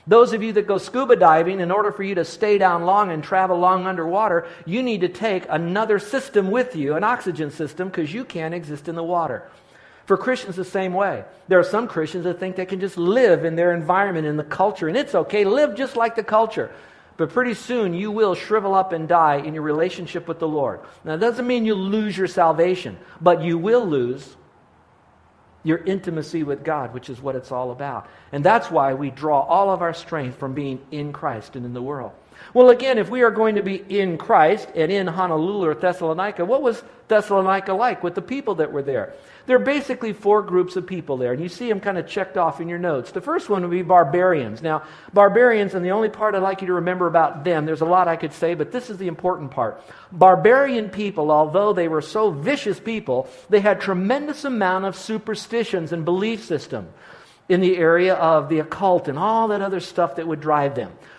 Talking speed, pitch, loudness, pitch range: 225 wpm, 185 Hz, -20 LUFS, 160-210 Hz